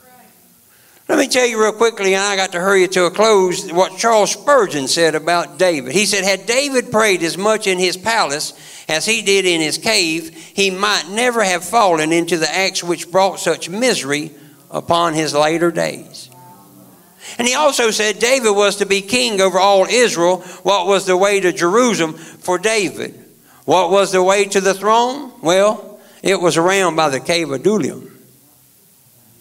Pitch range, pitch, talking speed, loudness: 170-215 Hz, 190 Hz, 180 wpm, -15 LUFS